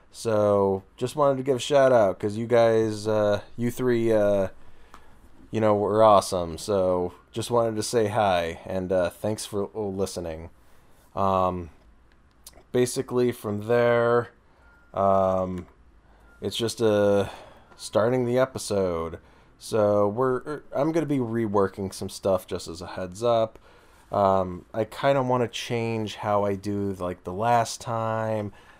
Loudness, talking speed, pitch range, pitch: -25 LUFS, 140 wpm, 95-120 Hz, 105 Hz